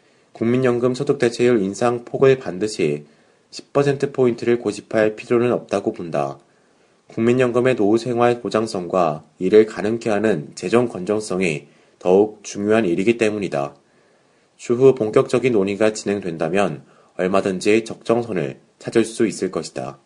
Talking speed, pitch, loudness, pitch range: 295 characters per minute, 110 Hz, -20 LUFS, 100-120 Hz